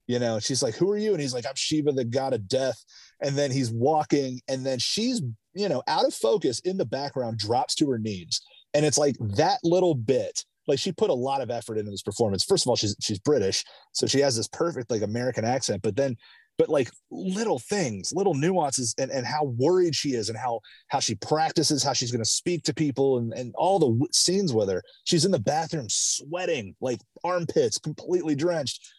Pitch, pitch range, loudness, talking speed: 140 Hz, 125-175 Hz, -26 LUFS, 225 wpm